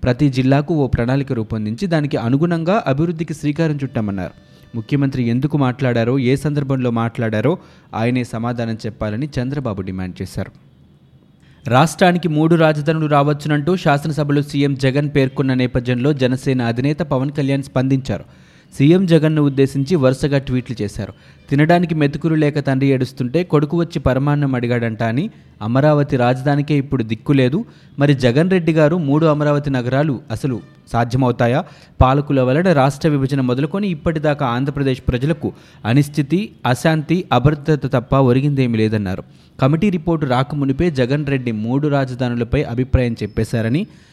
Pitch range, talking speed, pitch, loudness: 125-150 Hz, 120 wpm, 135 Hz, -17 LUFS